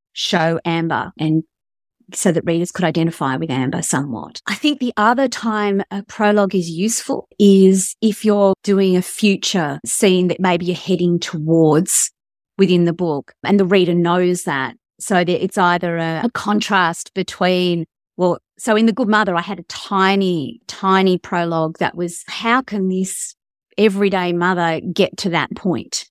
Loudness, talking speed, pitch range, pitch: -17 LUFS, 165 wpm, 170-200 Hz, 185 Hz